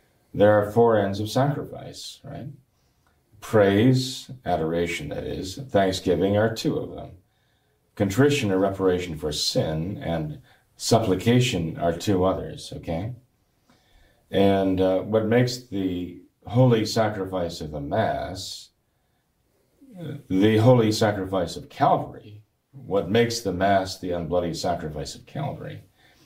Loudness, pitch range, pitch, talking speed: -23 LUFS, 95-125 Hz, 105 Hz, 120 wpm